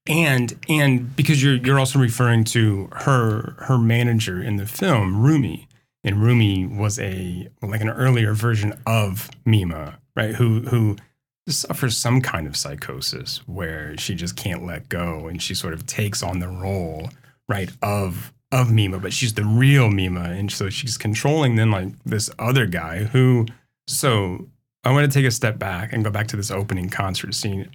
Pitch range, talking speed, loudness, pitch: 95-130 Hz, 175 wpm, -21 LUFS, 110 Hz